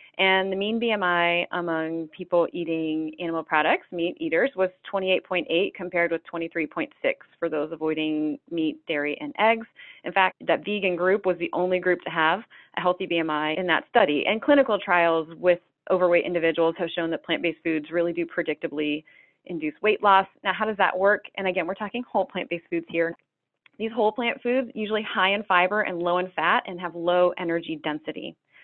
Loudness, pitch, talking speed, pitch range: -25 LUFS, 175 Hz, 185 wpm, 165-195 Hz